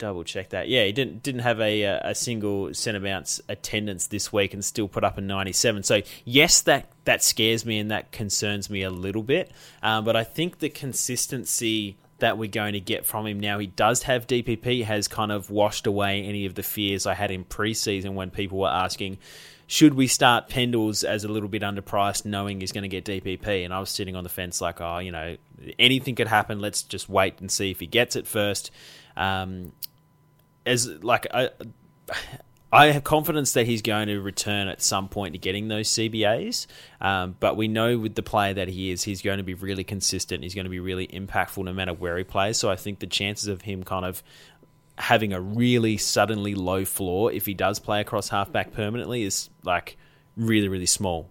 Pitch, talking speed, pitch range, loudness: 105 Hz, 210 wpm, 95-115 Hz, -24 LUFS